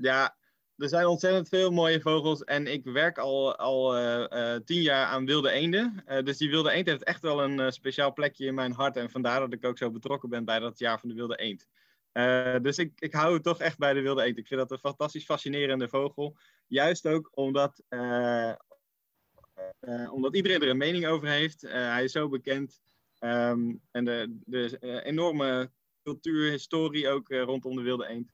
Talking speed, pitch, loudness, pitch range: 215 wpm, 135 Hz, -29 LUFS, 125-155 Hz